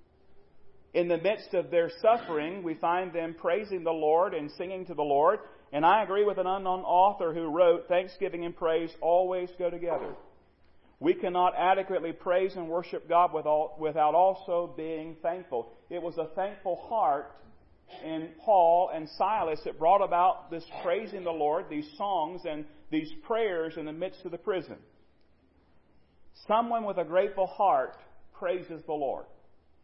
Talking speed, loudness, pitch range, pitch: 155 wpm, -29 LUFS, 160-185 Hz, 175 Hz